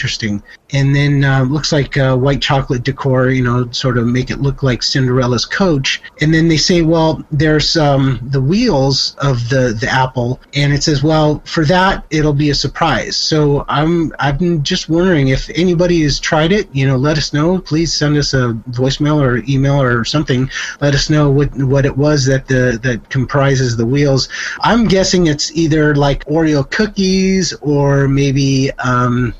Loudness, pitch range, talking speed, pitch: -13 LUFS, 130-155 Hz, 185 wpm, 140 Hz